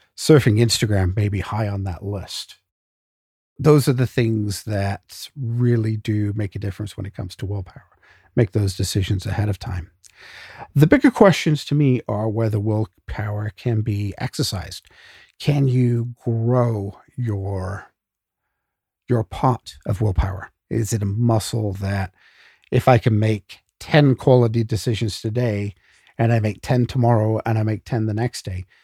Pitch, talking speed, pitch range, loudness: 110 Hz, 150 wpm, 100-120 Hz, -21 LUFS